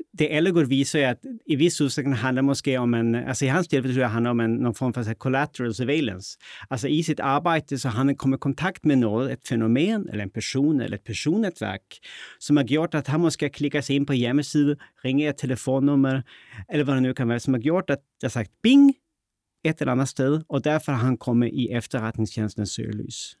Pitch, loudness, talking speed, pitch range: 135 Hz, -24 LUFS, 210 wpm, 120-150 Hz